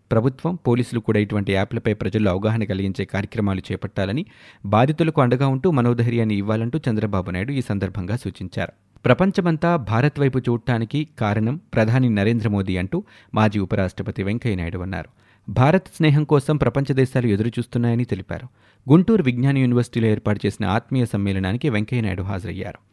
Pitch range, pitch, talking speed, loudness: 100-130 Hz, 115 Hz, 130 wpm, -21 LUFS